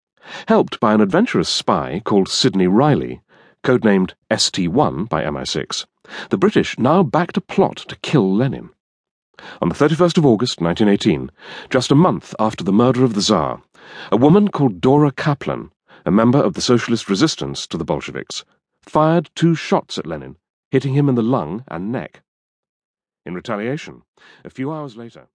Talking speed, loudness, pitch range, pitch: 160 wpm, -17 LUFS, 105-150 Hz, 130 Hz